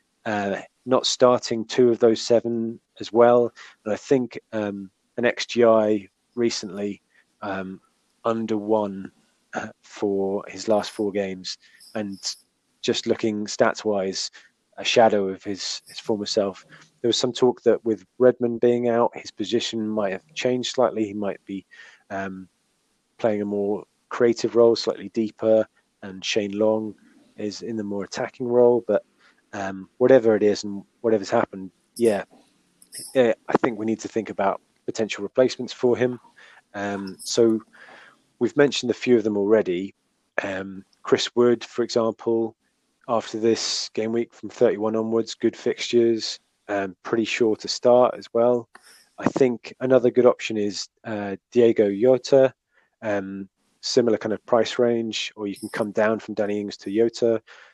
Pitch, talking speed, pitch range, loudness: 110 Hz, 155 wpm, 100-120 Hz, -23 LUFS